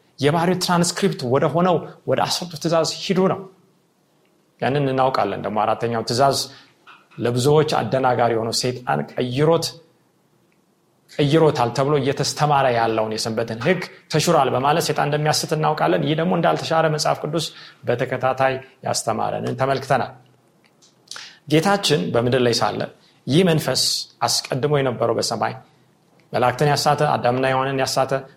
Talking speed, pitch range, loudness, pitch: 110 wpm, 130-165 Hz, -20 LUFS, 145 Hz